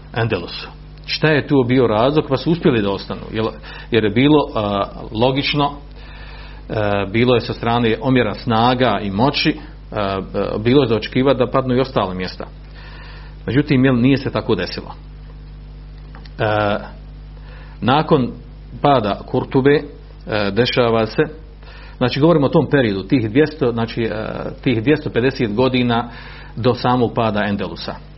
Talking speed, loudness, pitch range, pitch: 135 wpm, -17 LUFS, 110-140 Hz, 125 Hz